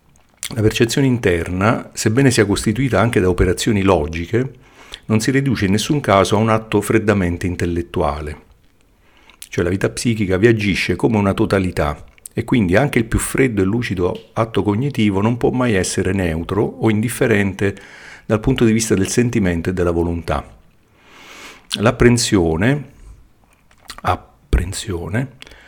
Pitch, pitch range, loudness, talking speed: 105 Hz, 90-120 Hz, -17 LUFS, 135 wpm